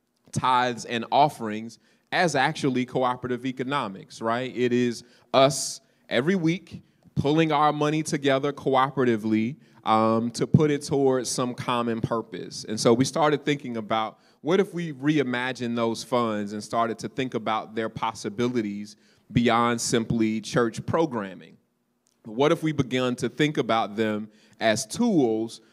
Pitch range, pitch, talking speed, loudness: 115-145 Hz, 125 Hz, 140 wpm, -25 LUFS